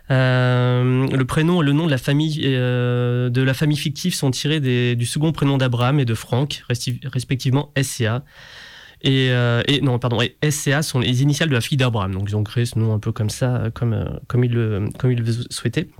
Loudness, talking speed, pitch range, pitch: -20 LUFS, 225 wpm, 120-140 Hz, 130 Hz